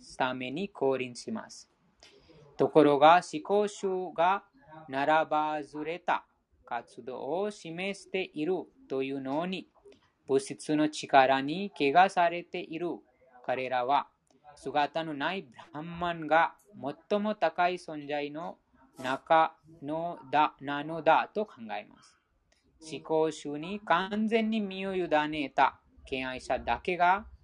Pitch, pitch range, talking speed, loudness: 160 Hz, 145-180 Hz, 210 characters per minute, -30 LUFS